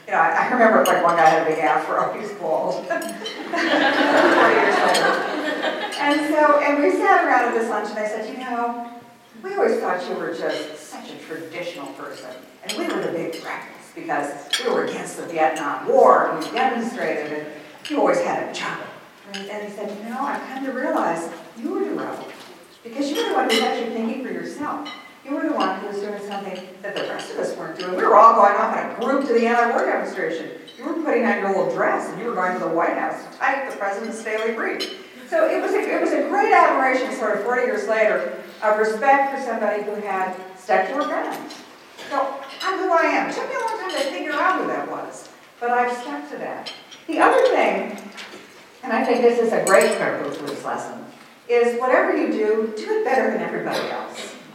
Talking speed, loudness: 220 wpm, -21 LUFS